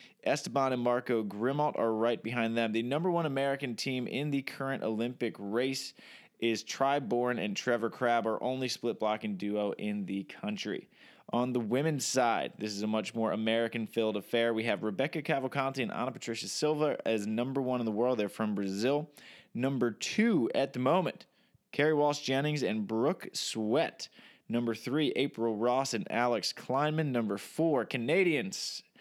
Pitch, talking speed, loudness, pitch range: 120 Hz, 170 wpm, -32 LUFS, 110-135 Hz